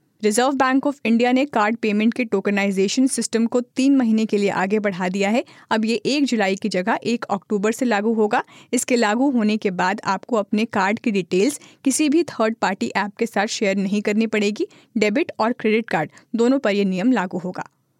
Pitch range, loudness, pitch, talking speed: 200-245 Hz, -20 LUFS, 220 Hz, 205 wpm